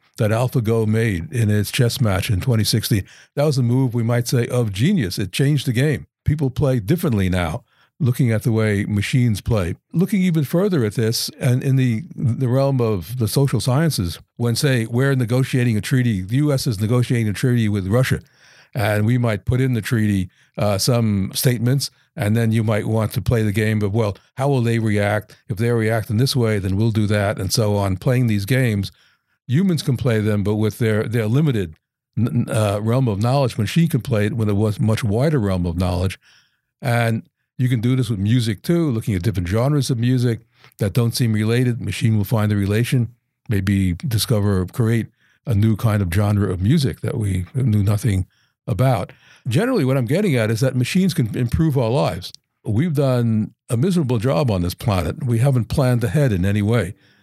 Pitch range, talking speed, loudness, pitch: 105-130 Hz, 200 wpm, -19 LUFS, 115 Hz